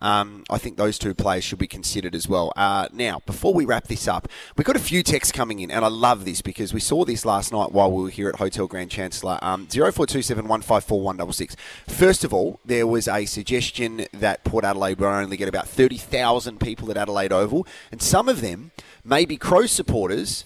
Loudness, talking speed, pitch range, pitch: -22 LUFS, 220 wpm, 95-115 Hz, 105 Hz